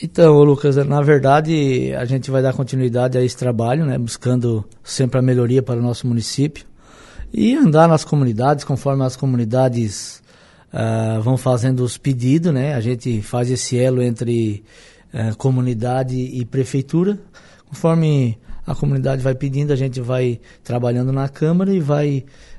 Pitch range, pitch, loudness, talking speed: 125-145 Hz, 130 Hz, -18 LUFS, 150 wpm